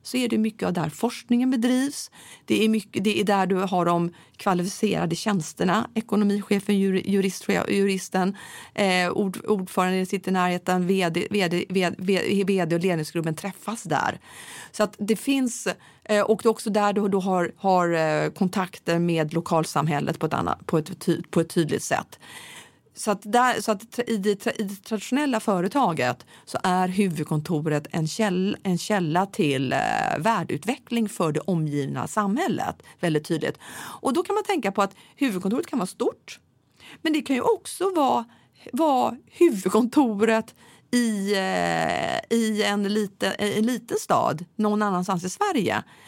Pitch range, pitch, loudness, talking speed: 180-220 Hz, 200 Hz, -24 LUFS, 155 wpm